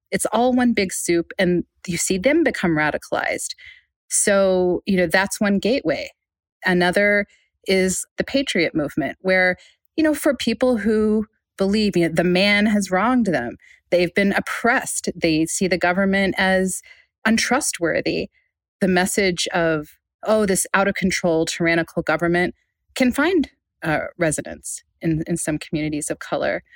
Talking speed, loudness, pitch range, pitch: 145 wpm, -20 LUFS, 175-220 Hz, 190 Hz